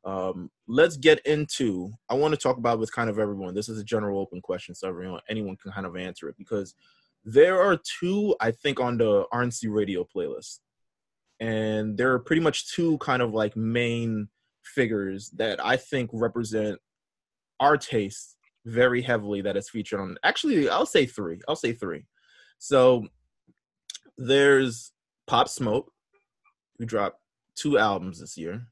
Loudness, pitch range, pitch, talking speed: -25 LUFS, 100-125 Hz, 115 Hz, 165 wpm